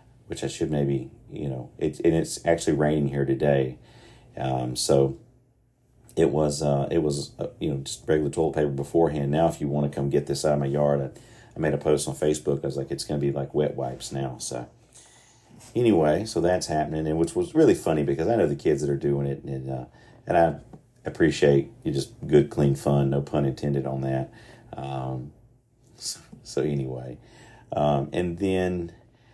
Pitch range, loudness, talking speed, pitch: 70-85 Hz, -25 LUFS, 200 wpm, 75 Hz